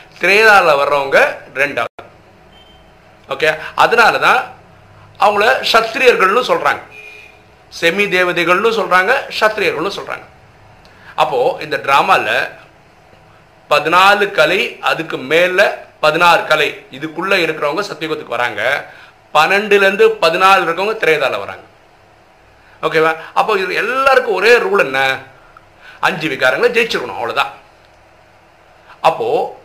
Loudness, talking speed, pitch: -13 LUFS, 90 wpm, 160 Hz